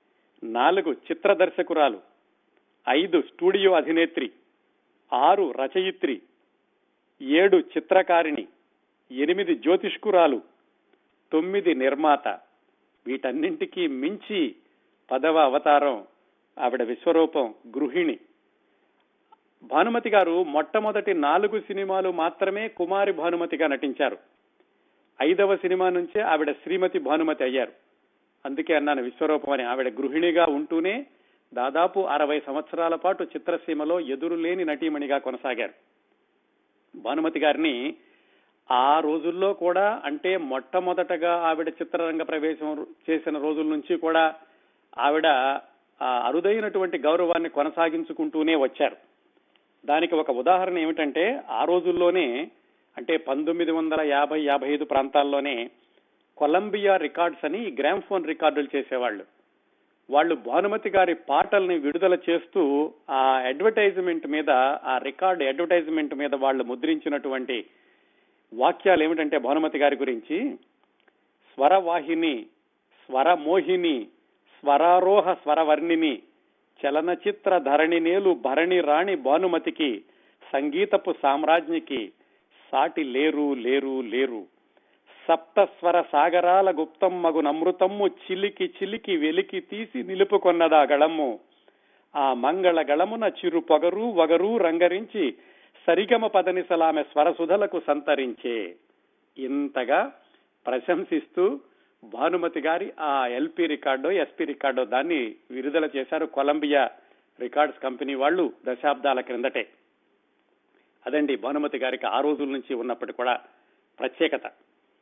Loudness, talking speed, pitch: -24 LUFS, 95 wpm, 175 Hz